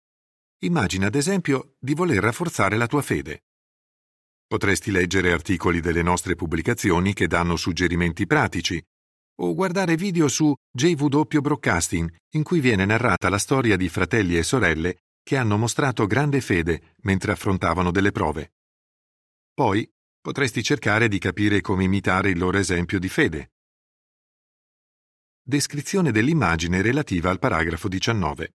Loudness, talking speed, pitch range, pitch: -22 LUFS, 130 wpm, 90-135 Hz, 100 Hz